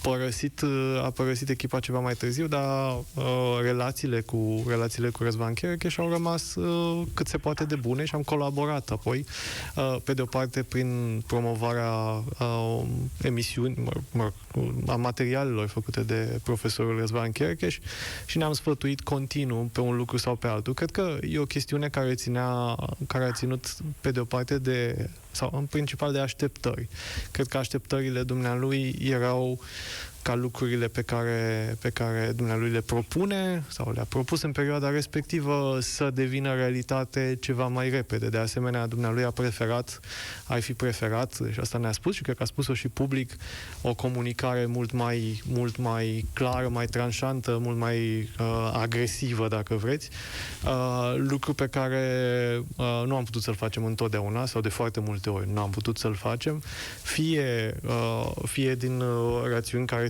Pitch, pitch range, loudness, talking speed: 125 Hz, 115-135 Hz, -29 LUFS, 165 wpm